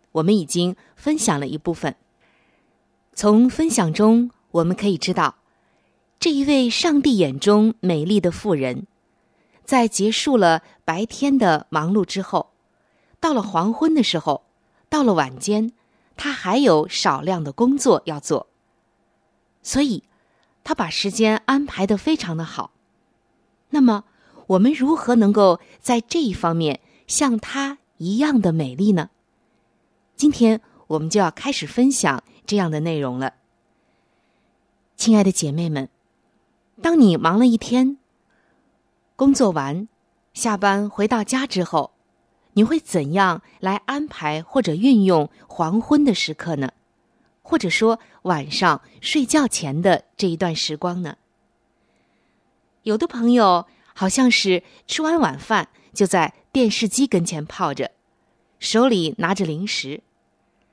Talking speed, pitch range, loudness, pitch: 190 characters per minute, 170-255 Hz, -20 LUFS, 210 Hz